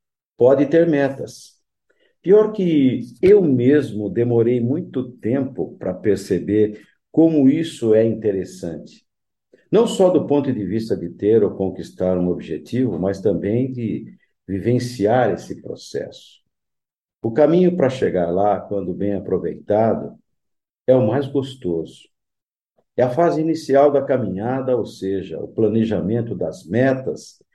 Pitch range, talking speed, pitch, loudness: 100-140 Hz, 125 wpm, 125 Hz, -19 LUFS